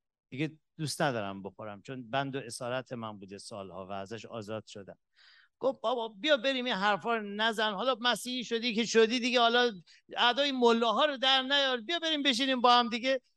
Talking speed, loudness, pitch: 185 wpm, -29 LUFS, 225 Hz